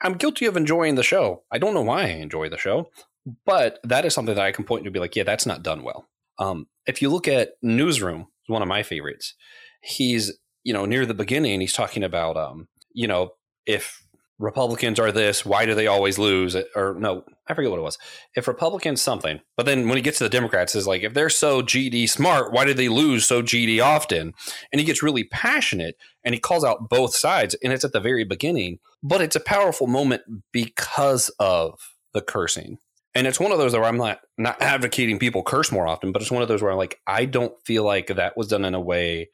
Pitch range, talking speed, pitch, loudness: 100-140 Hz, 230 wpm, 120 Hz, -22 LUFS